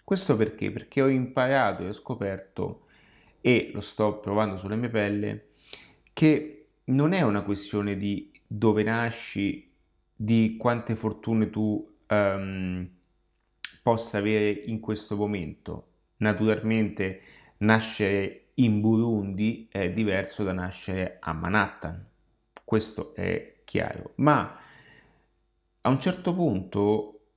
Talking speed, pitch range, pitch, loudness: 110 wpm, 100-115 Hz, 105 Hz, -27 LUFS